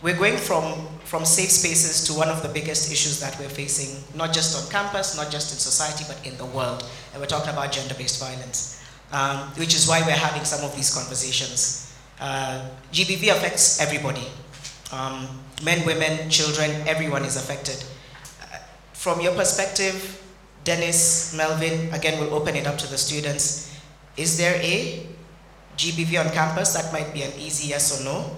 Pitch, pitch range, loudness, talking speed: 150 Hz, 140-165 Hz, -22 LUFS, 175 wpm